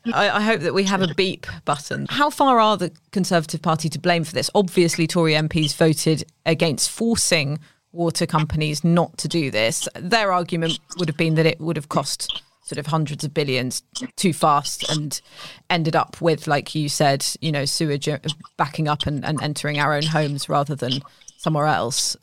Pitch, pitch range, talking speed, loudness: 160 Hz, 150-175 Hz, 185 wpm, -21 LUFS